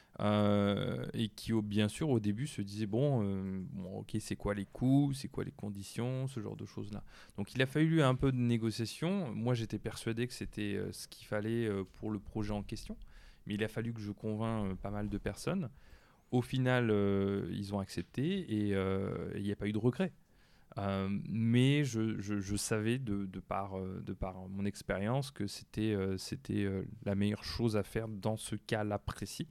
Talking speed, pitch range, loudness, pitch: 210 wpm, 100-120 Hz, -36 LUFS, 110 Hz